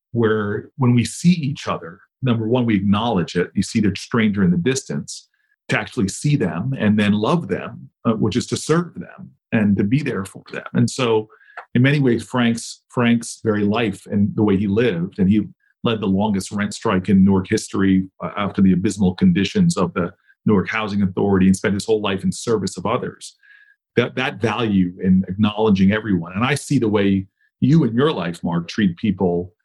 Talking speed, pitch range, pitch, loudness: 200 wpm, 100-135 Hz, 110 Hz, -19 LUFS